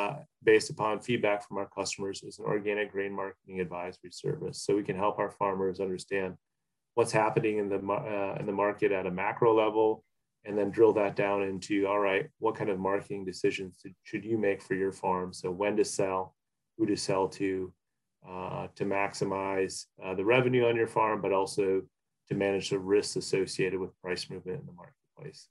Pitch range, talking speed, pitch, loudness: 95-105 Hz, 190 wpm, 100 Hz, -30 LUFS